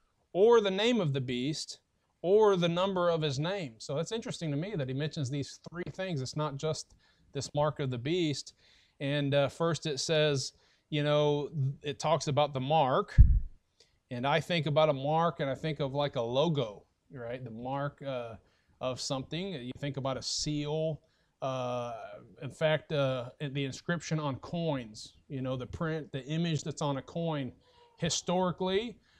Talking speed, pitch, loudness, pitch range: 175 wpm, 150 Hz, -32 LUFS, 135-165 Hz